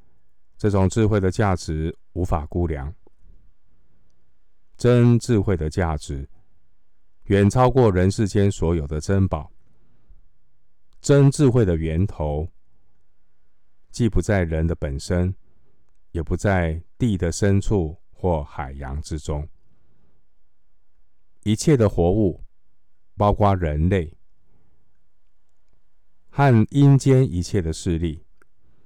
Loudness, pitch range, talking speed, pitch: -21 LUFS, 80-105 Hz, 145 characters per minute, 90 Hz